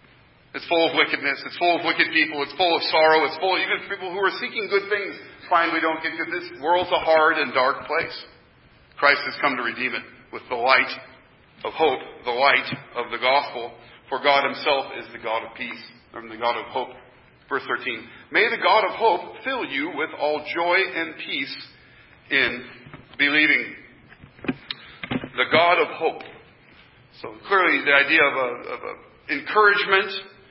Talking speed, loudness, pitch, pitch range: 180 wpm, -21 LUFS, 155 Hz, 135-175 Hz